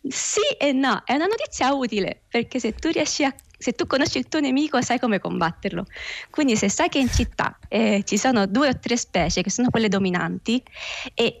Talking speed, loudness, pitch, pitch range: 205 wpm, -22 LUFS, 245 Hz, 205-280 Hz